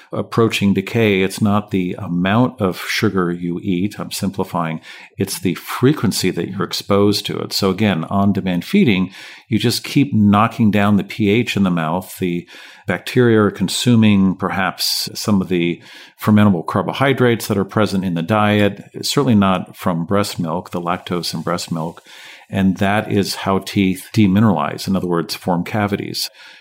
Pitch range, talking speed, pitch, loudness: 90-105 Hz, 160 wpm, 100 Hz, -17 LUFS